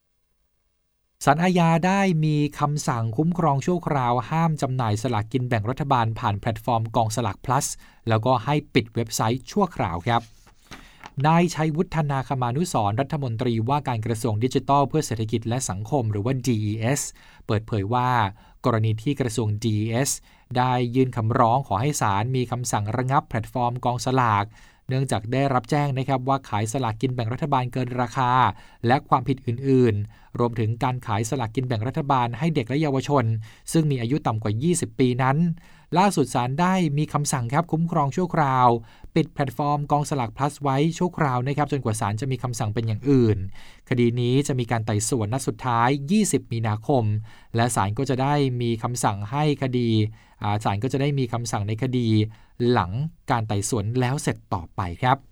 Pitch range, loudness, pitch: 115-145 Hz, -24 LUFS, 125 Hz